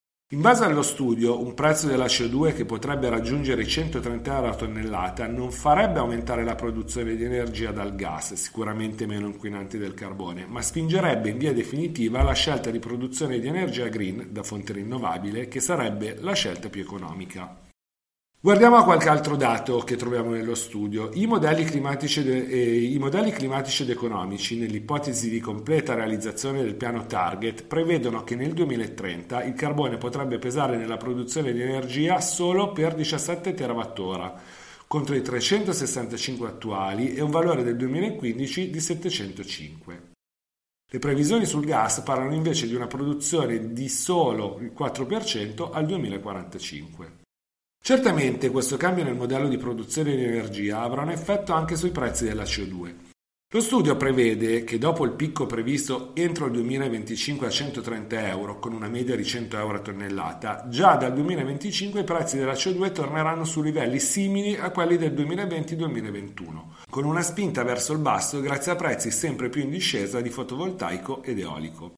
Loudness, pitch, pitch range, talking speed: -25 LUFS, 125 Hz, 115-155 Hz, 155 wpm